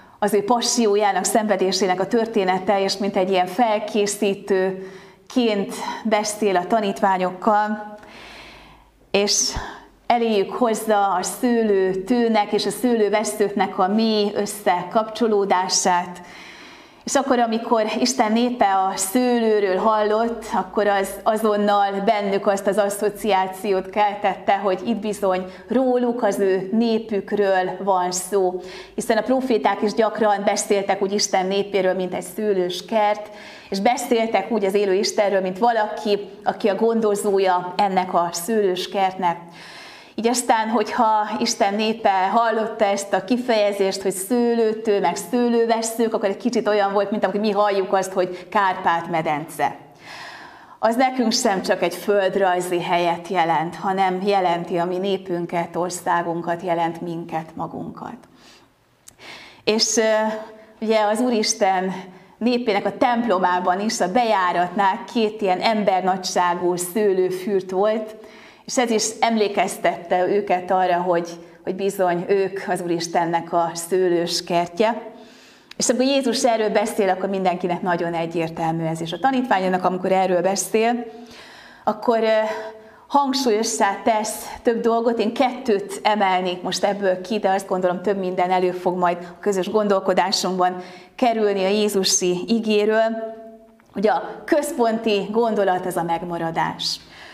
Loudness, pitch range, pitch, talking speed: -20 LUFS, 185-220 Hz, 200 Hz, 125 wpm